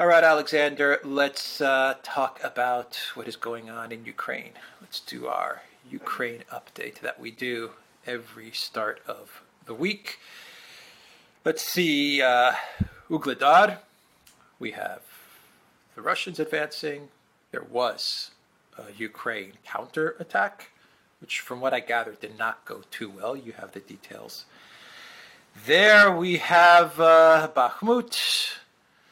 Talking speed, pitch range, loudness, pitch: 125 wpm, 130-175 Hz, -23 LUFS, 155 Hz